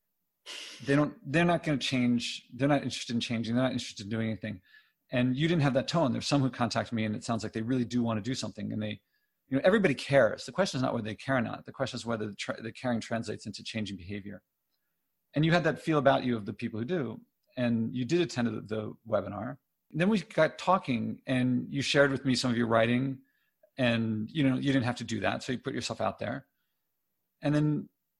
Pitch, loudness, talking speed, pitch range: 125 Hz, -30 LUFS, 250 wpm, 115-140 Hz